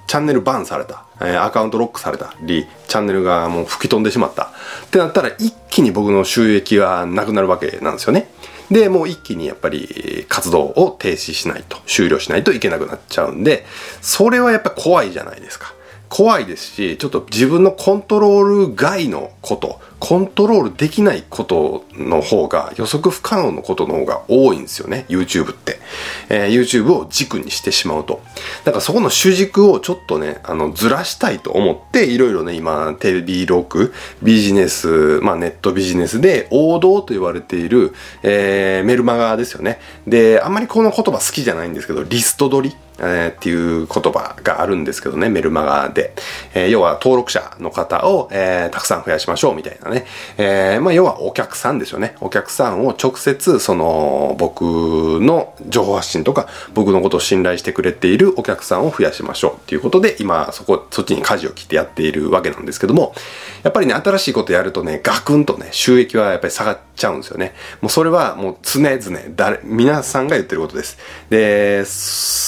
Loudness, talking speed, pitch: -16 LUFS, 410 characters per minute, 115 Hz